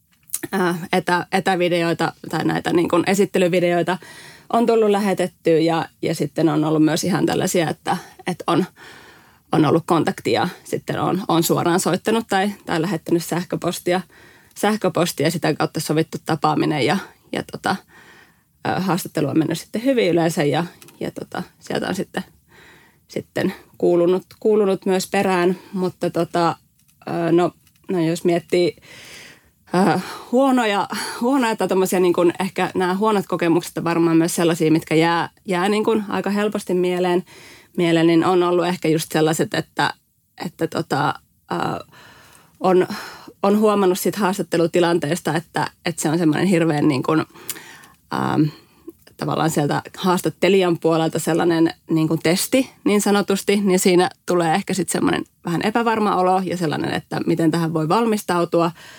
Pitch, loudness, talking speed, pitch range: 175 Hz, -20 LUFS, 135 wpm, 165-185 Hz